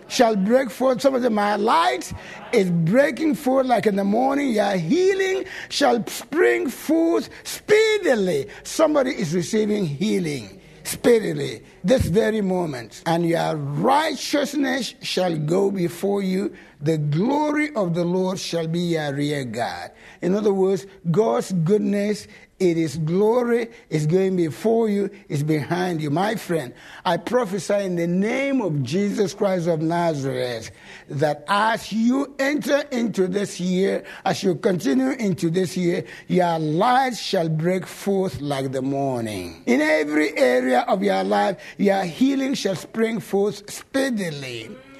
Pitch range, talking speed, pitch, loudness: 165-235 Hz, 140 wpm, 195 Hz, -22 LUFS